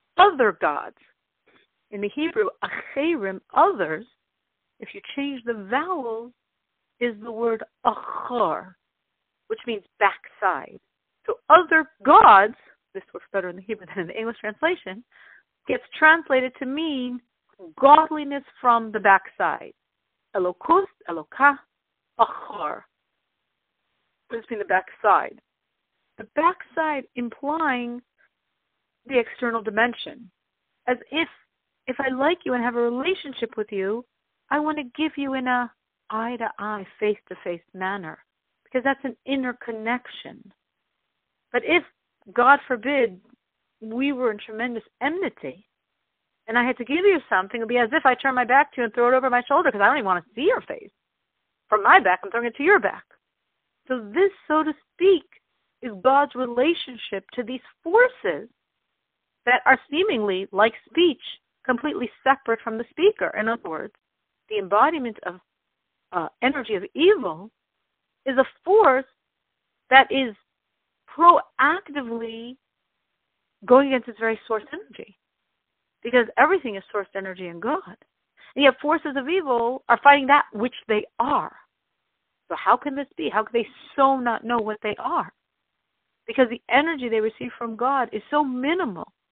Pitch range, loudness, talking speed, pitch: 225-295 Hz, -22 LUFS, 150 wpm, 250 Hz